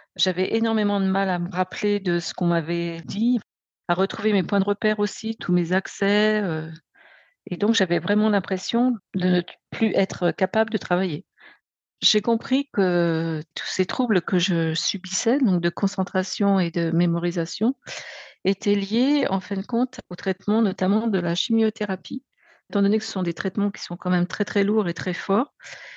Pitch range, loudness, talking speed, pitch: 180-215 Hz, -23 LUFS, 185 wpm, 195 Hz